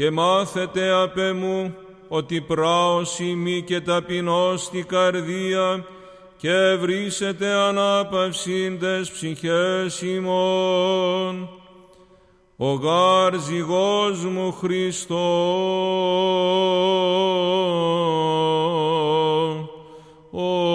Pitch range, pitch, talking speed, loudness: 175-185 Hz, 185 Hz, 60 wpm, -21 LUFS